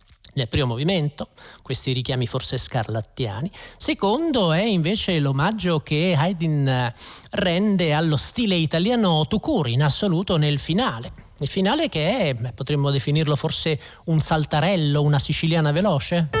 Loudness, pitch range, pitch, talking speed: -21 LUFS, 140-180 Hz, 155 Hz, 125 wpm